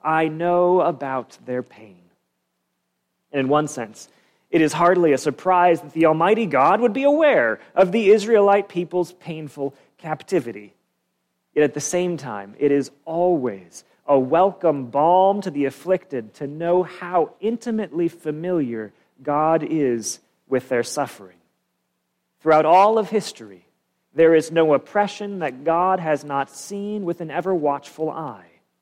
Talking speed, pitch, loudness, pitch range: 145 wpm, 160 Hz, -20 LUFS, 135-180 Hz